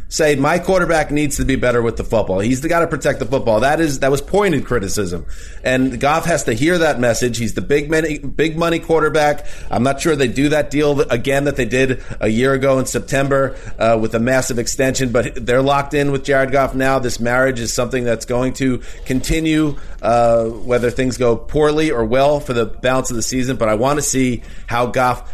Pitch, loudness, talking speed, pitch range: 130 Hz, -17 LUFS, 220 wpm, 120-145 Hz